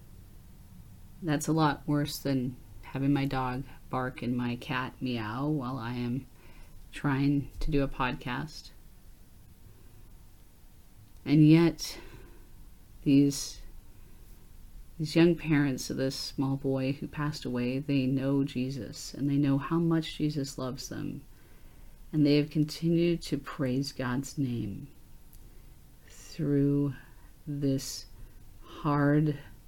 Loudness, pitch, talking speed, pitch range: -30 LUFS, 135 Hz, 115 wpm, 105-145 Hz